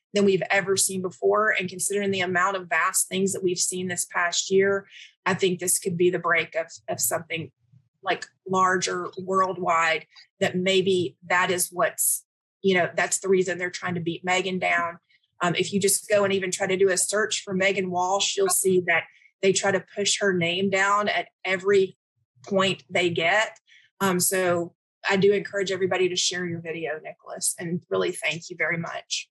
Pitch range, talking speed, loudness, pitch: 175-195 Hz, 190 wpm, -24 LUFS, 185 Hz